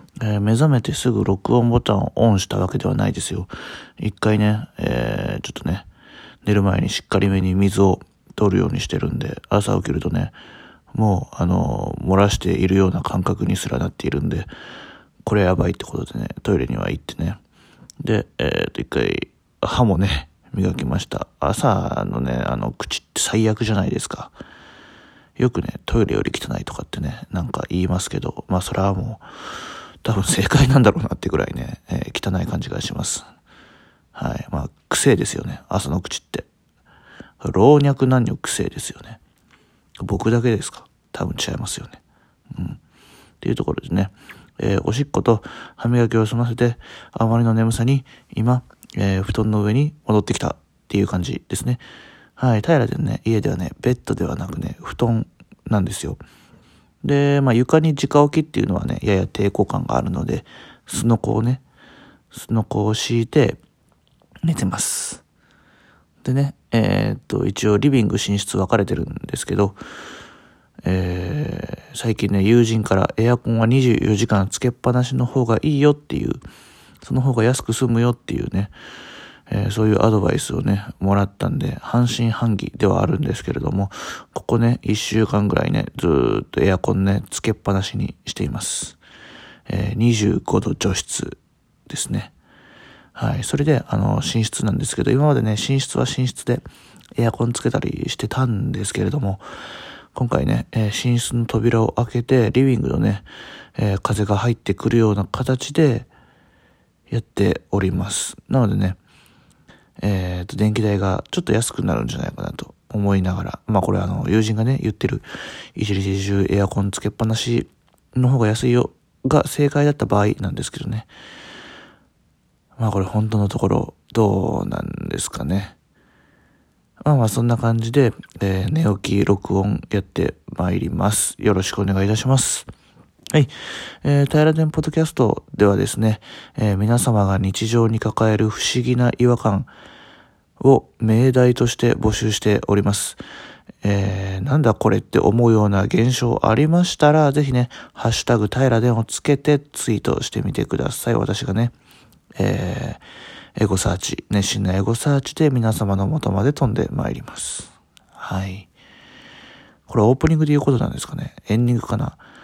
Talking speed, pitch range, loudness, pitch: 325 characters per minute, 100-125 Hz, -20 LUFS, 110 Hz